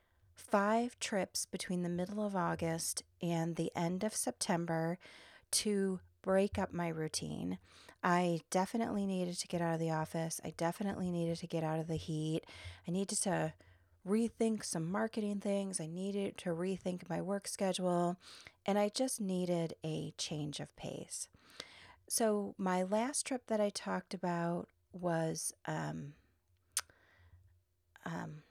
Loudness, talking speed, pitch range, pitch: -37 LUFS, 145 wpm, 155-200 Hz, 175 Hz